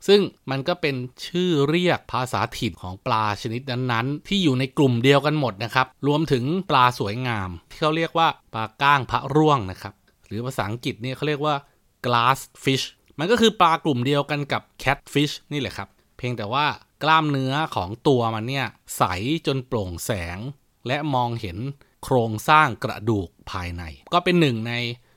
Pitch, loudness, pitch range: 130 Hz, -23 LUFS, 115-150 Hz